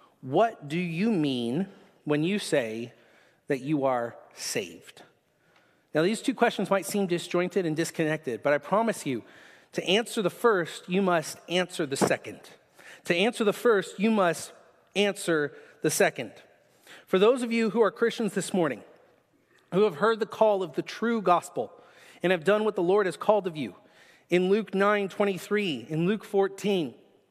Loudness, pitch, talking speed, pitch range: -27 LUFS, 190 Hz, 165 wpm, 170-210 Hz